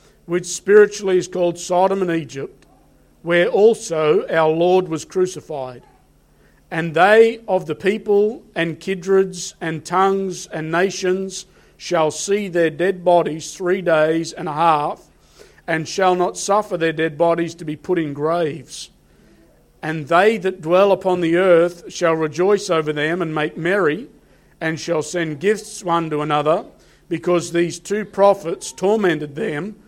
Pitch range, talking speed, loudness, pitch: 160-190 Hz, 145 wpm, -18 LUFS, 175 Hz